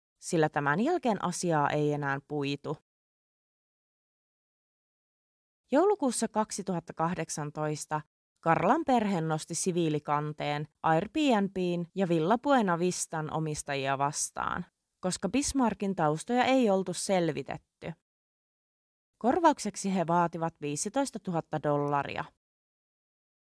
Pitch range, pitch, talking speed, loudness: 150-205 Hz, 170 Hz, 80 wpm, -30 LUFS